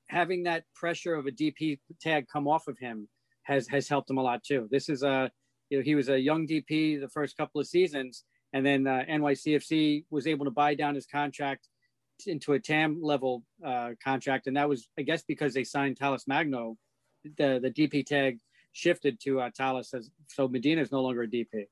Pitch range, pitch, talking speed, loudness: 130-150 Hz, 140 Hz, 205 wpm, -30 LUFS